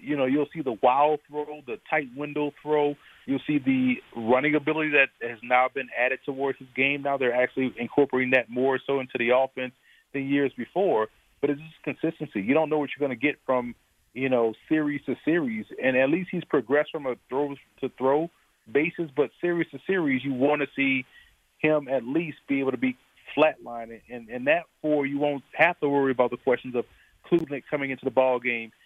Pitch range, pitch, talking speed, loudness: 130-150 Hz, 140 Hz, 210 wpm, -26 LUFS